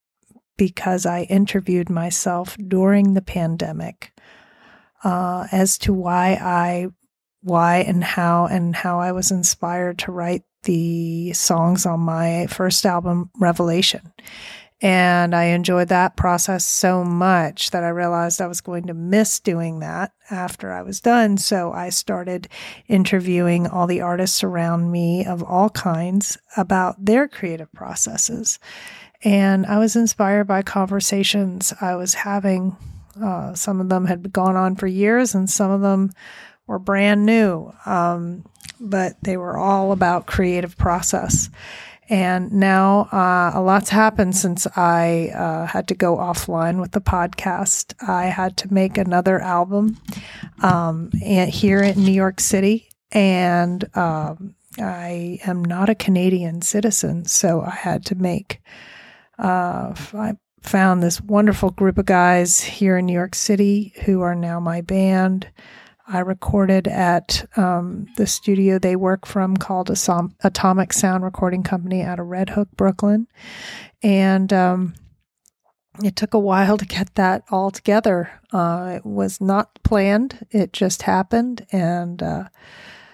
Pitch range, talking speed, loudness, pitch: 175-200 Hz, 145 wpm, -19 LUFS, 185 Hz